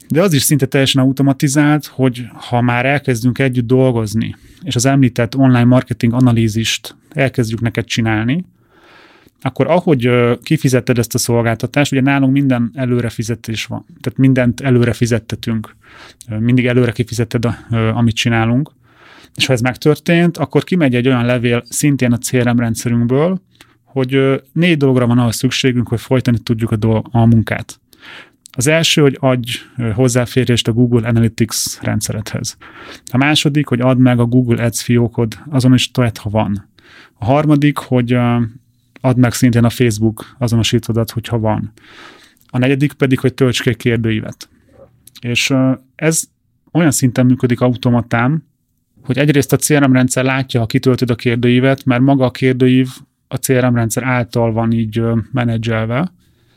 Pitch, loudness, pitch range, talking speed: 125 Hz, -14 LUFS, 120-135 Hz, 145 wpm